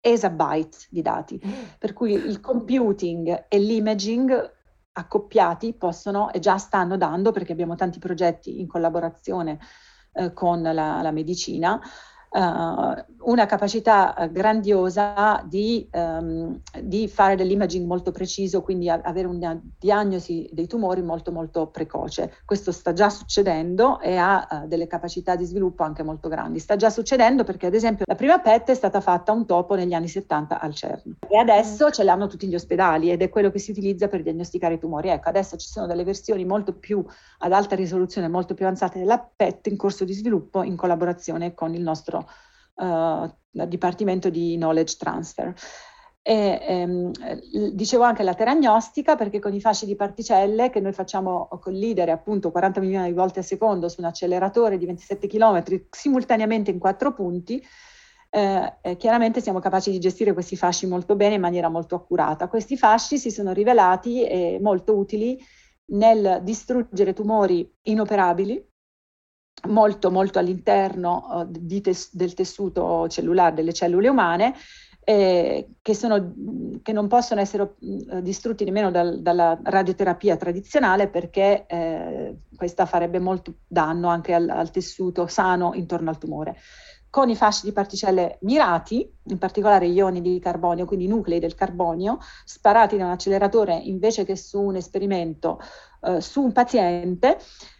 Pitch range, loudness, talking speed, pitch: 175-210 Hz, -22 LUFS, 155 wpm, 190 Hz